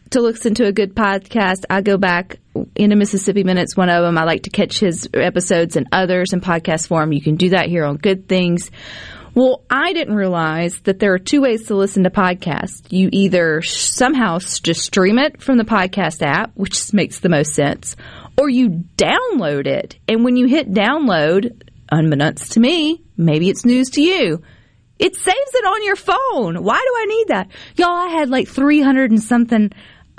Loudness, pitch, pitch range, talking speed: -16 LUFS, 200 Hz, 175-255 Hz, 195 wpm